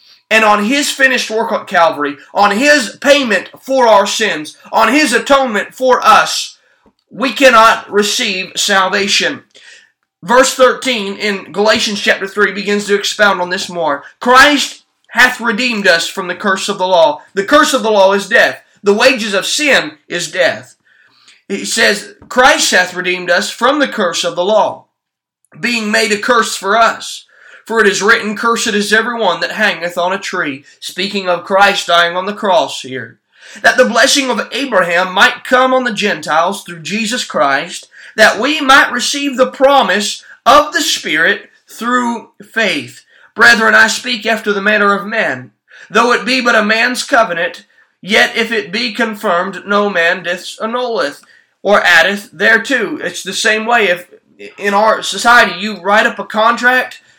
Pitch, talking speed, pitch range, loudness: 215 Hz, 170 wpm, 195-245 Hz, -11 LUFS